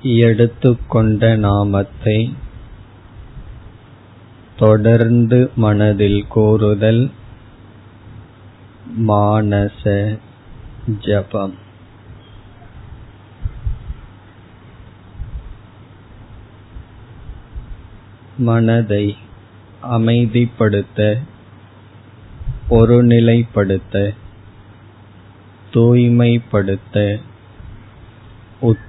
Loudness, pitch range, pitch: -15 LUFS, 100-115 Hz, 105 Hz